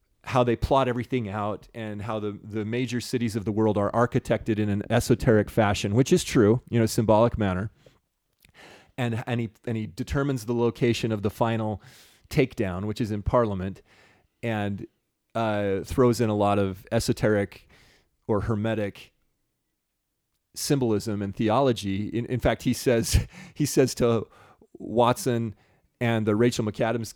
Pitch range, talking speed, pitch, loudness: 105-120 Hz, 150 wpm, 115 Hz, -25 LUFS